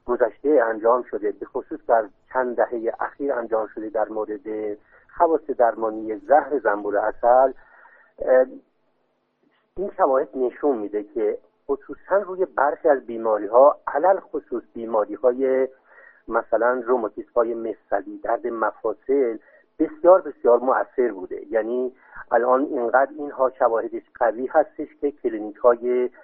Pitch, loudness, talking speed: 130 Hz, -22 LUFS, 120 wpm